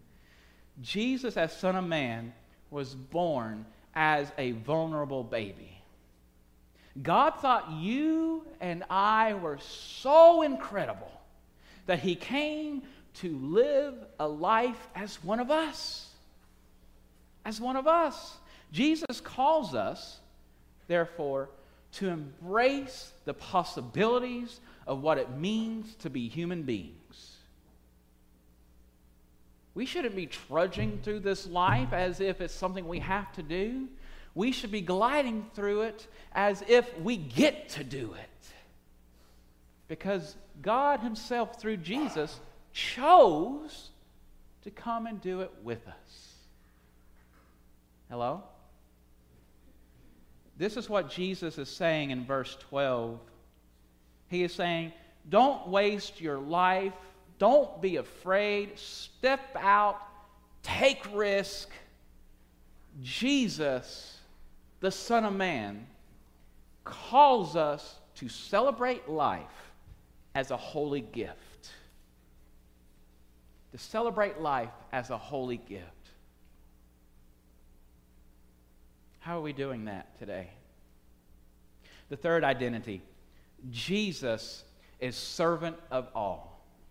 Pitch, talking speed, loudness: 150 Hz, 105 wpm, -30 LUFS